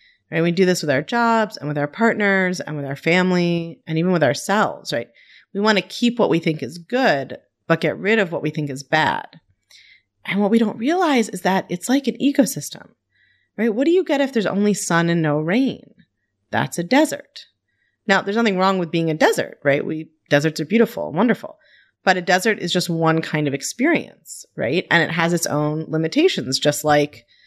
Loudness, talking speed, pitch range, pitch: -19 LUFS, 215 wpm, 155-220 Hz, 180 Hz